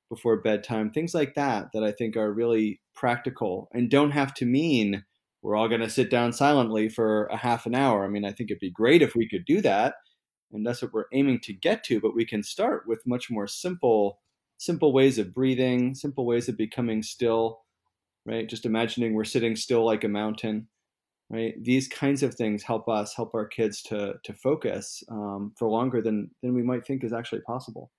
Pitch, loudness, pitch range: 115 Hz, -26 LUFS, 110-125 Hz